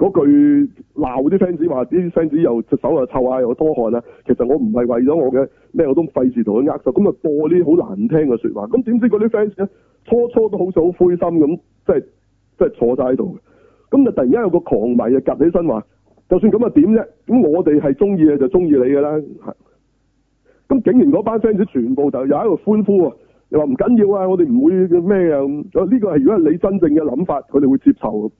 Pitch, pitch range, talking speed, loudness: 180 Hz, 140-225 Hz, 335 characters per minute, -15 LUFS